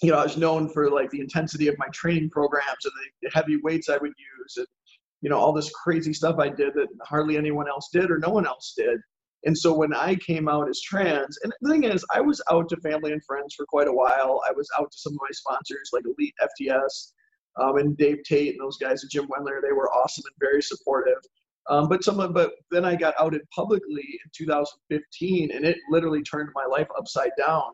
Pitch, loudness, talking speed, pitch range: 155 Hz, -25 LUFS, 235 wpm, 145-190 Hz